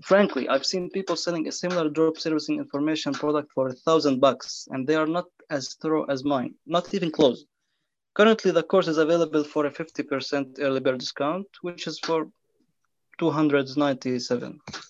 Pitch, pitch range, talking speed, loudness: 155 Hz, 140-170 Hz, 160 wpm, -25 LUFS